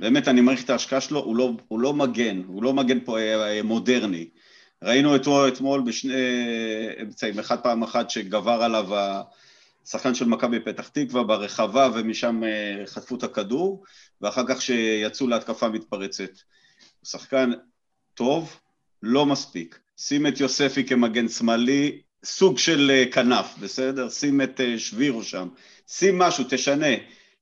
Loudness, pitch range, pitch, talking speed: -23 LUFS, 110-135 Hz, 125 Hz, 135 wpm